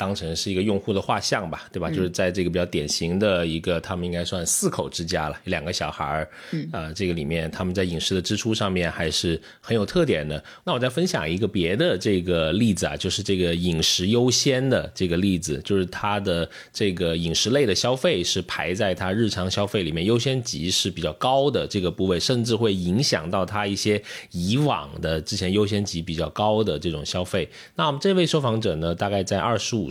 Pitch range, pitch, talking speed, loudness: 85-110 Hz, 95 Hz, 325 characters per minute, -23 LUFS